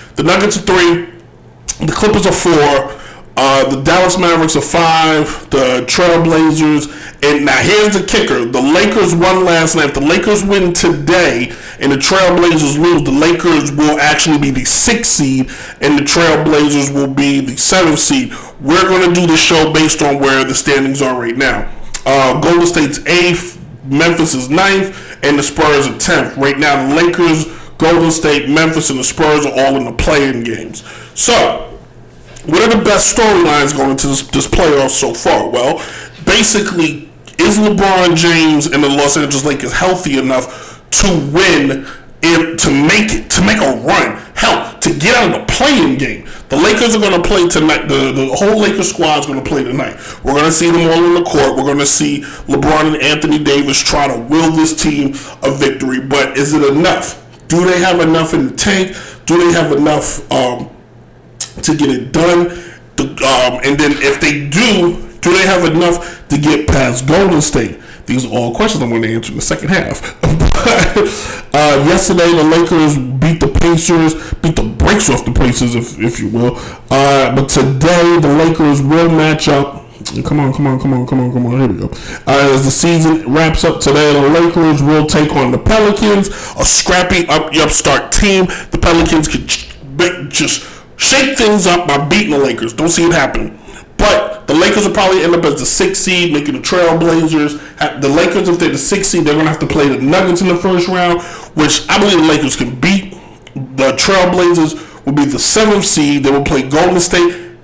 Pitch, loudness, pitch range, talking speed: 155 Hz, -10 LUFS, 140-175 Hz, 195 wpm